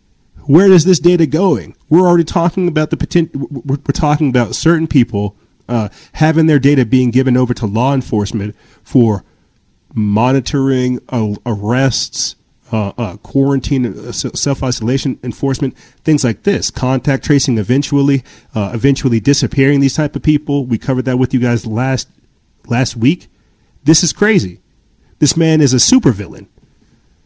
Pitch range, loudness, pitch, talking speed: 120-150 Hz, -13 LUFS, 135 Hz, 145 wpm